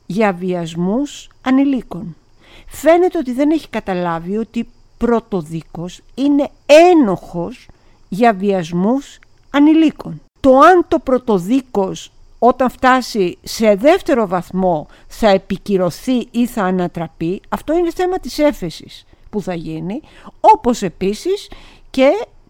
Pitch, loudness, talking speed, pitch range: 225 Hz, -15 LUFS, 105 wpm, 185-275 Hz